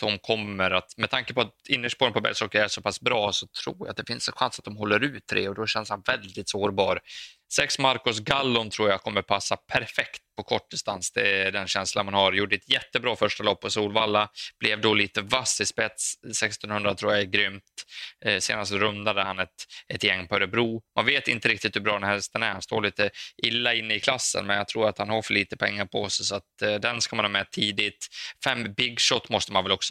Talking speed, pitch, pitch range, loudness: 245 wpm, 105 Hz, 100-115 Hz, -25 LUFS